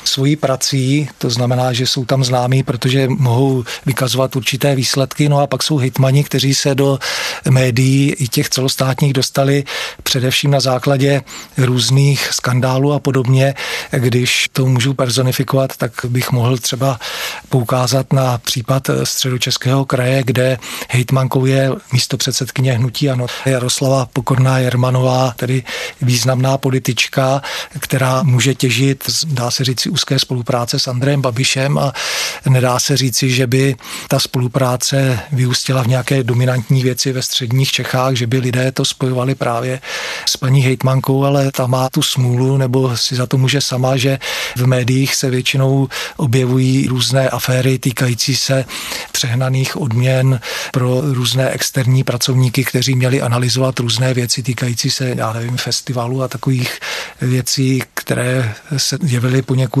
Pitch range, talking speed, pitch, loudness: 125-135 Hz, 140 wpm, 130 Hz, -15 LUFS